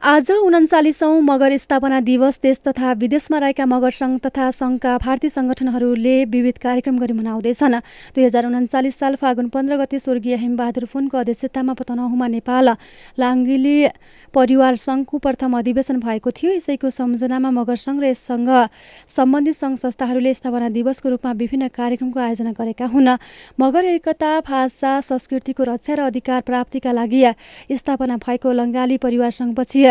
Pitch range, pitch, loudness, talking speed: 245-270 Hz, 260 Hz, -18 LUFS, 140 wpm